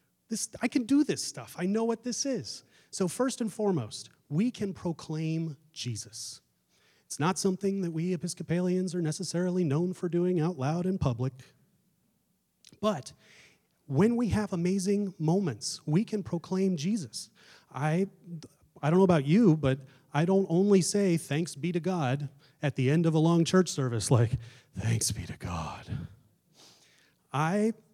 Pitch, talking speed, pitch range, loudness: 175 Hz, 155 wpm, 145-195 Hz, -29 LUFS